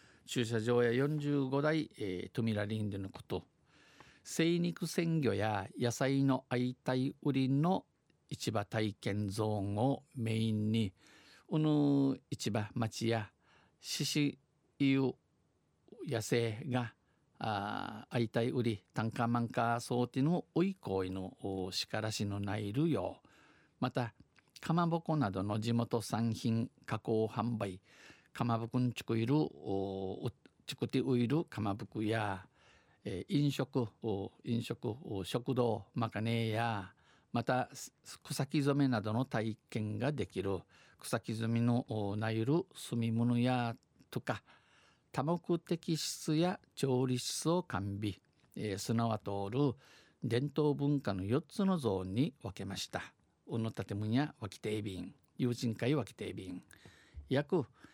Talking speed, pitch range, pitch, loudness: 205 characters per minute, 110-140 Hz, 120 Hz, -36 LUFS